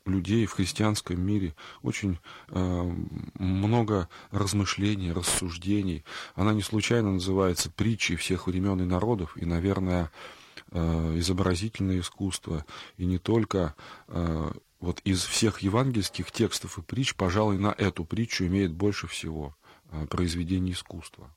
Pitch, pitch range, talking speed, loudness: 95 Hz, 85-105 Hz, 125 wpm, -28 LUFS